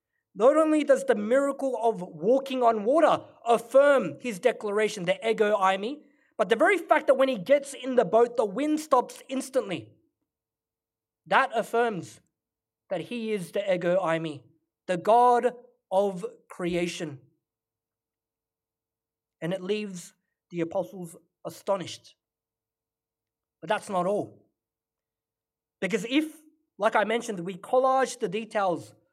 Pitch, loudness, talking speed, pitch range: 215 Hz, -26 LUFS, 130 wpm, 170-255 Hz